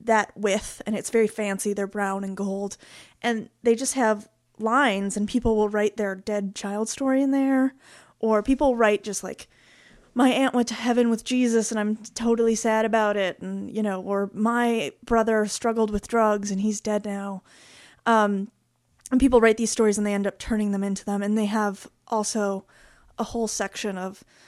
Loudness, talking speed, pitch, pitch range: -24 LUFS, 190 wpm, 215 Hz, 205-230 Hz